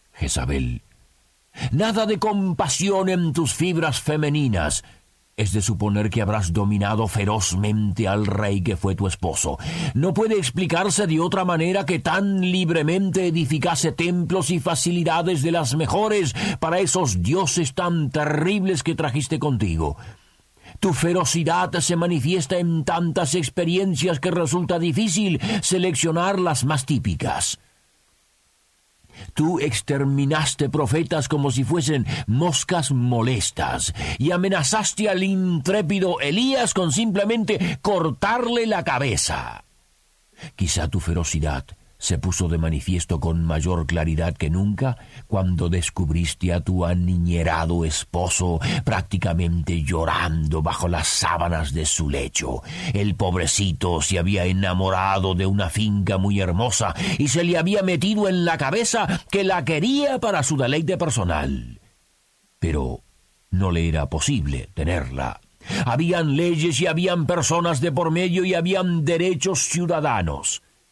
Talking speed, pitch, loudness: 125 wpm, 150 Hz, -22 LUFS